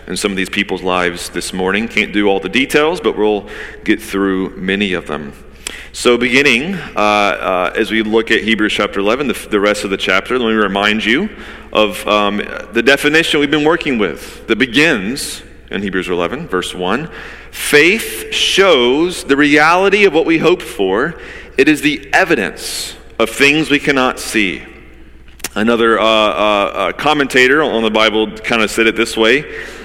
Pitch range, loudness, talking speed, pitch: 100-140 Hz, -13 LUFS, 175 wpm, 110 Hz